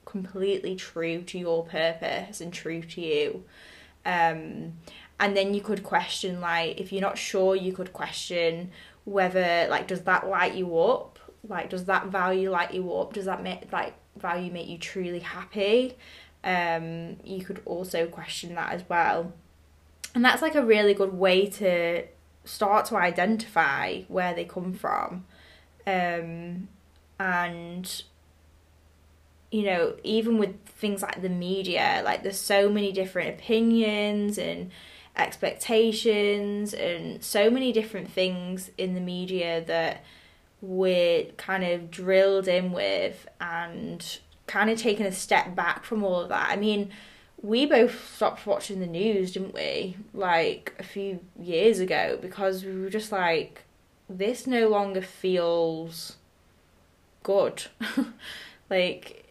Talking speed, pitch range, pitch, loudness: 140 wpm, 170-205 Hz, 185 Hz, -27 LUFS